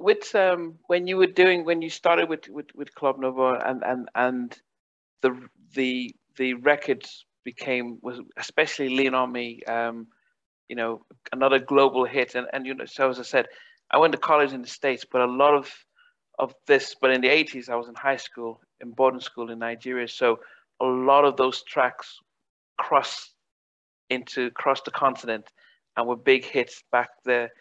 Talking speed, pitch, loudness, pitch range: 185 wpm, 130 Hz, -24 LUFS, 120-145 Hz